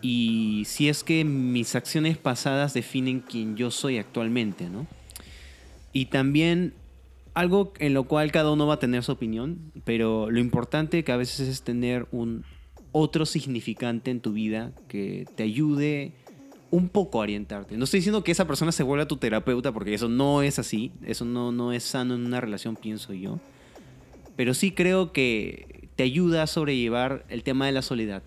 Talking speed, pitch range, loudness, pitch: 180 wpm, 115-150 Hz, -26 LUFS, 125 Hz